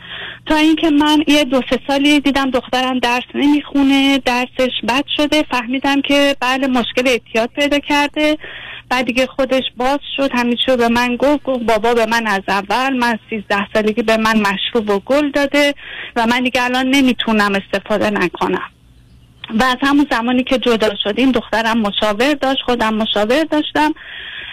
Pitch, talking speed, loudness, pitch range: 255 Hz, 160 wpm, -15 LUFS, 225-280 Hz